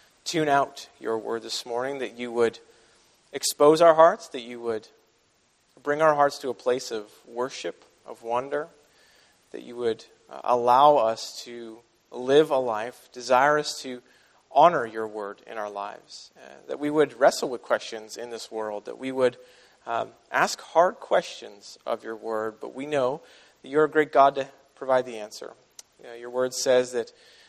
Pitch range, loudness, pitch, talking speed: 115-140 Hz, -24 LUFS, 125 Hz, 175 wpm